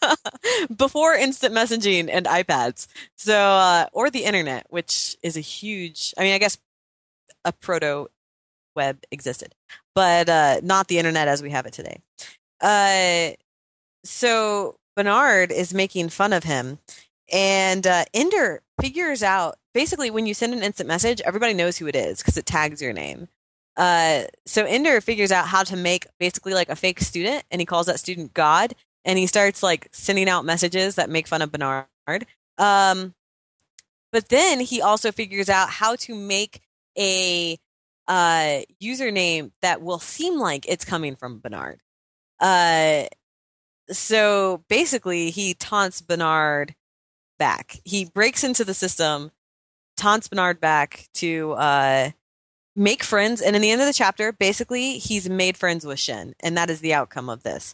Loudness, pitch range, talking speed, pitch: -21 LUFS, 155-210 Hz, 160 wpm, 185 Hz